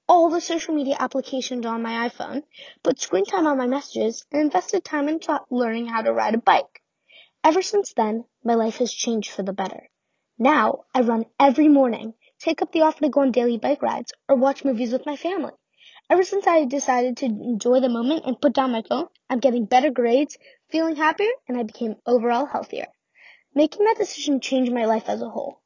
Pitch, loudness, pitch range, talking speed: 270 Hz, -22 LUFS, 240-310 Hz, 205 wpm